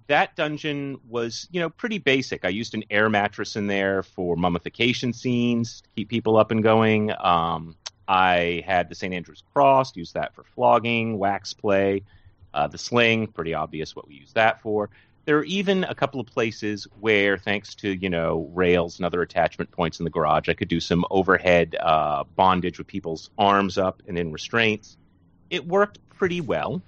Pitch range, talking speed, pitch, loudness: 90-120 Hz, 190 wpm, 100 Hz, -23 LUFS